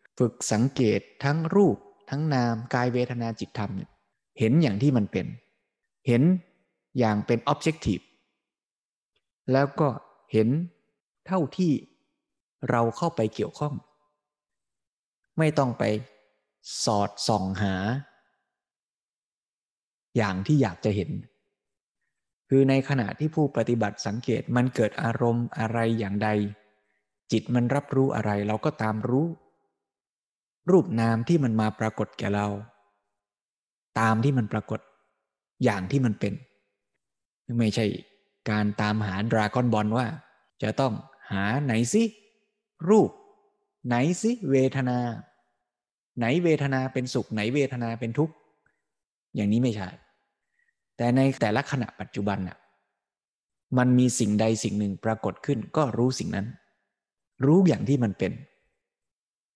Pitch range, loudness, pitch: 105-140 Hz, -26 LUFS, 120 Hz